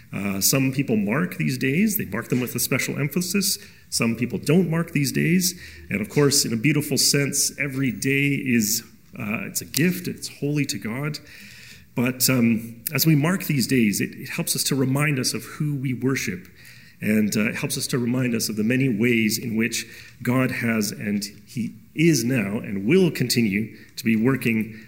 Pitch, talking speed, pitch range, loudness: 130 Hz, 195 wpm, 115-150 Hz, -22 LUFS